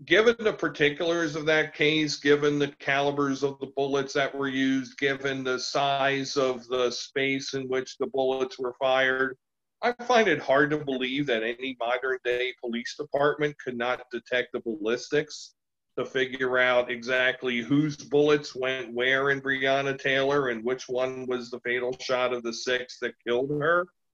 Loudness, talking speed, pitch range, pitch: -26 LUFS, 170 wpm, 125-145 Hz, 135 Hz